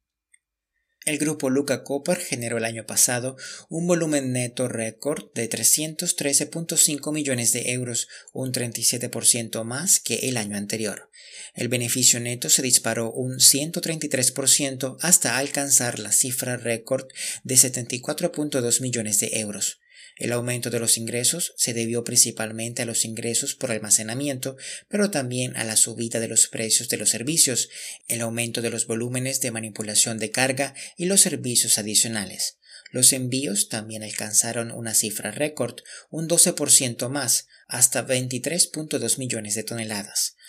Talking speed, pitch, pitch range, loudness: 140 wpm, 125 Hz, 115-140 Hz, -21 LUFS